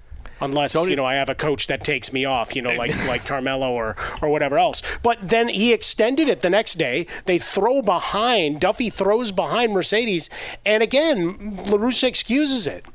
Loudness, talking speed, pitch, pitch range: -20 LUFS, 185 wpm, 190 Hz, 140-230 Hz